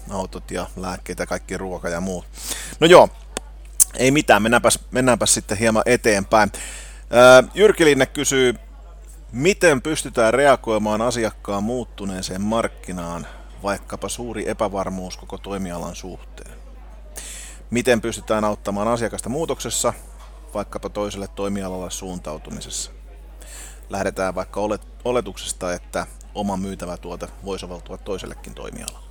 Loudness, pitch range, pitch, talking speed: -20 LUFS, 90-115 Hz, 100 Hz, 105 wpm